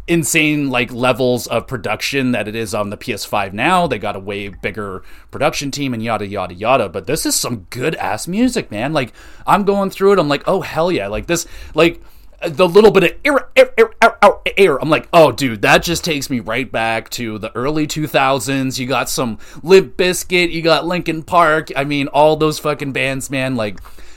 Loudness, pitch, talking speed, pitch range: -16 LUFS, 145 Hz, 210 wpm, 120-170 Hz